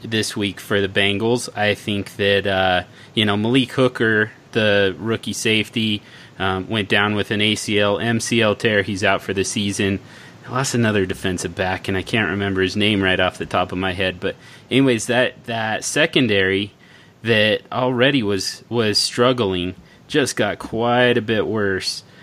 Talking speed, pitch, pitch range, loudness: 170 wpm, 105 Hz, 100-115 Hz, -19 LUFS